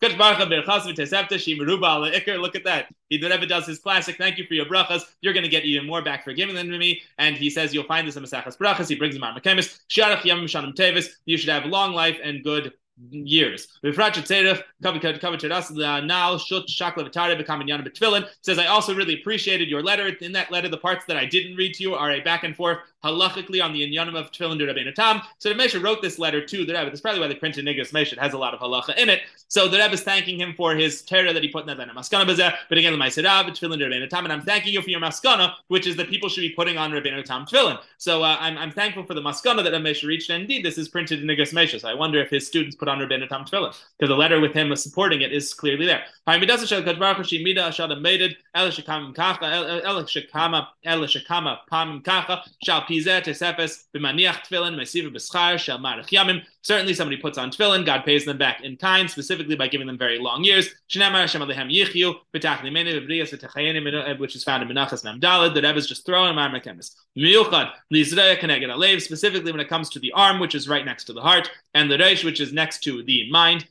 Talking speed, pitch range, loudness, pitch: 185 wpm, 150-185 Hz, -21 LUFS, 165 Hz